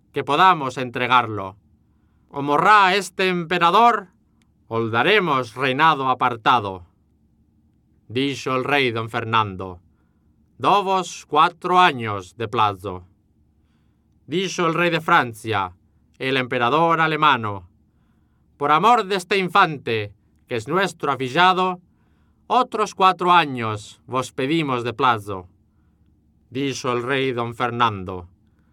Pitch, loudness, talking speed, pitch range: 125 Hz, -19 LUFS, 105 wpm, 100-165 Hz